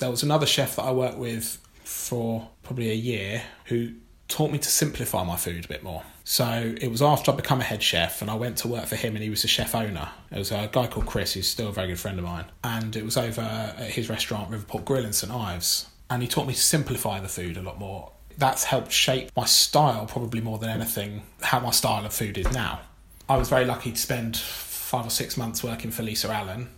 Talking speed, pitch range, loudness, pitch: 250 wpm, 100-125 Hz, -26 LUFS, 115 Hz